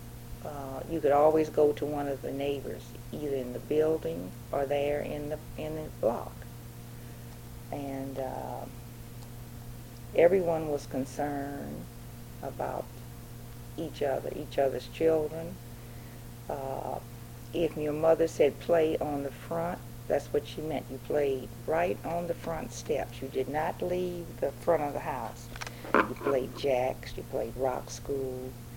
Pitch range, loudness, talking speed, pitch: 120-155 Hz, -31 LUFS, 140 wpm, 135 Hz